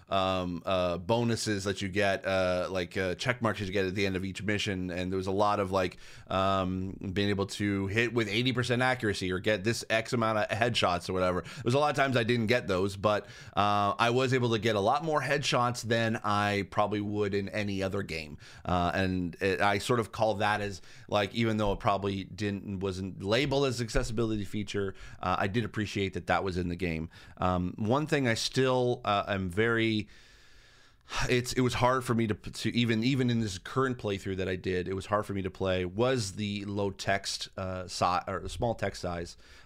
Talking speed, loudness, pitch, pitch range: 220 wpm, -30 LUFS, 105 Hz, 95-115 Hz